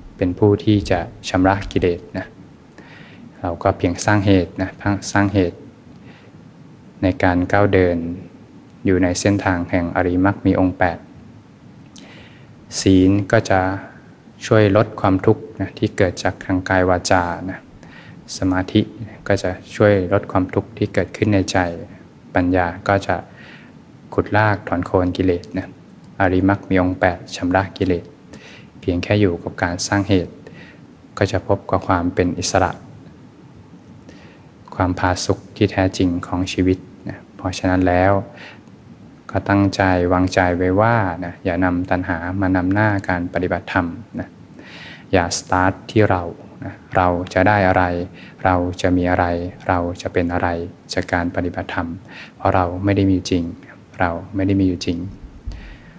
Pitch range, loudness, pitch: 90-100 Hz, -19 LUFS, 95 Hz